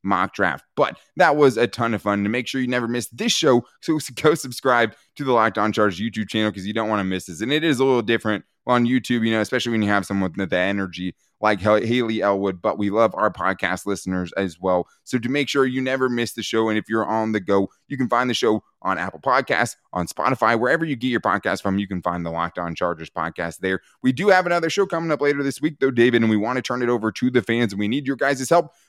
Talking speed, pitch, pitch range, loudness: 270 wpm, 115 Hz, 100-130 Hz, -21 LUFS